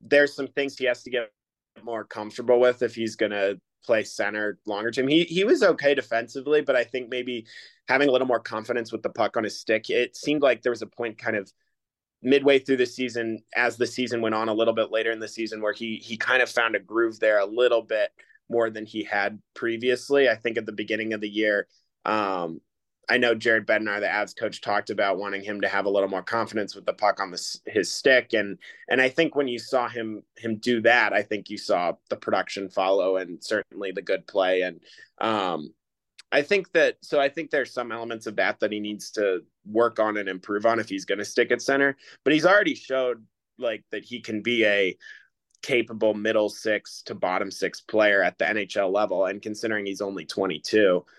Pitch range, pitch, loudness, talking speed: 105-125 Hz, 115 Hz, -25 LUFS, 225 wpm